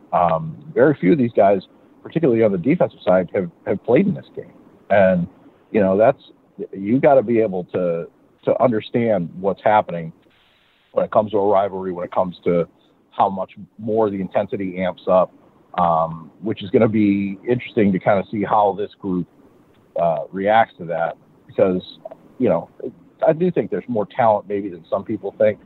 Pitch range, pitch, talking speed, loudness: 90-110 Hz, 100 Hz, 185 wpm, -19 LUFS